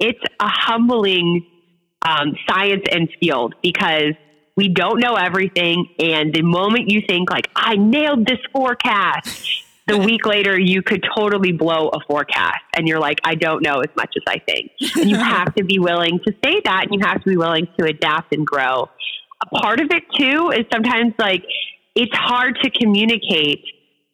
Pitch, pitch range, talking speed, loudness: 195 Hz, 170-230 Hz, 180 wpm, -17 LUFS